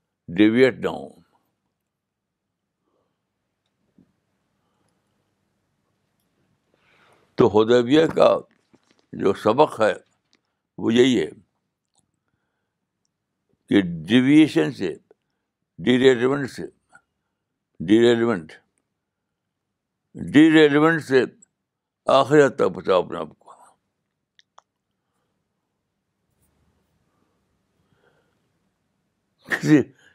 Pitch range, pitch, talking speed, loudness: 115-150 Hz, 130 Hz, 50 wpm, -19 LUFS